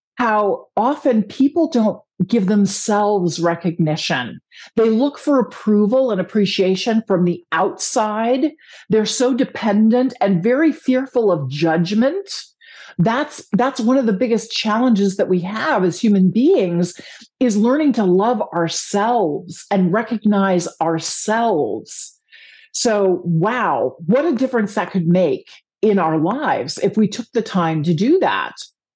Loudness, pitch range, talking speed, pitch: -17 LUFS, 185-255 Hz, 135 wpm, 215 Hz